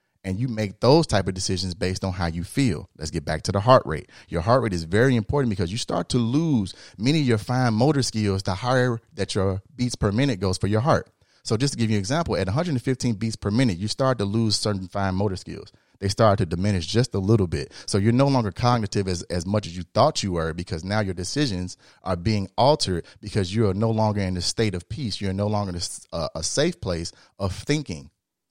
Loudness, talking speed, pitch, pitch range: -24 LUFS, 240 wpm, 105 Hz, 95-120 Hz